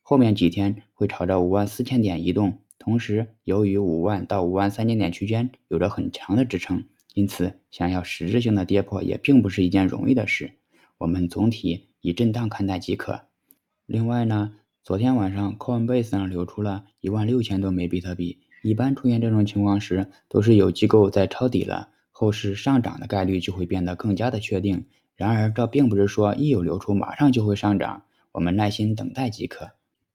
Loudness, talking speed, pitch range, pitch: -23 LUFS, 305 characters per minute, 95-115 Hz, 100 Hz